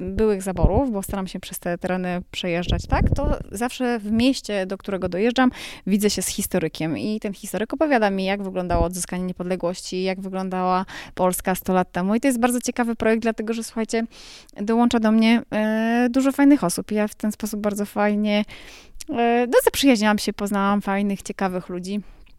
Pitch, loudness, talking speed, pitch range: 205 Hz, -22 LUFS, 180 wpm, 185-230 Hz